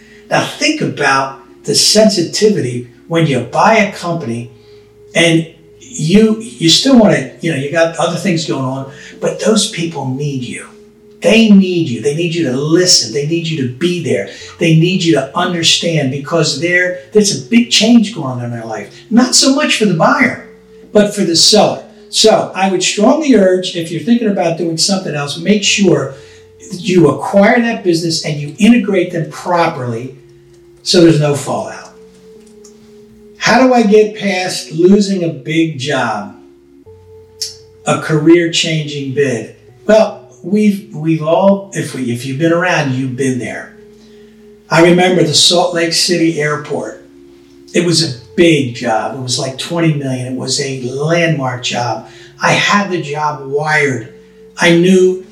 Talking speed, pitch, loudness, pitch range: 160 wpm, 170 Hz, -12 LUFS, 140-205 Hz